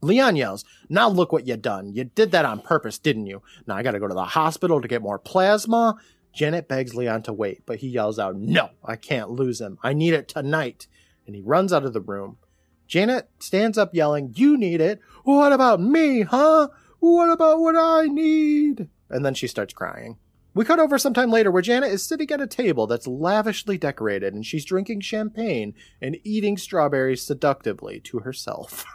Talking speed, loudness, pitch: 200 wpm, -21 LUFS, 170 Hz